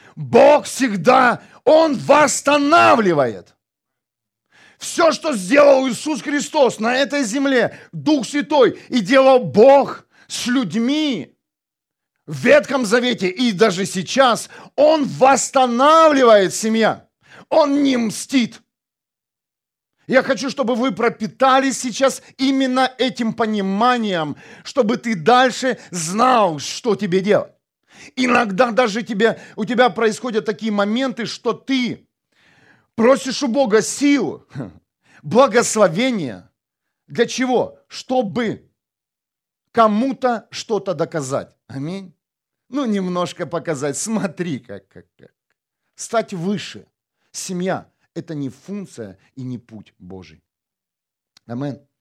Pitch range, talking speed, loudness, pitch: 195-265 Hz, 100 wpm, -17 LUFS, 240 Hz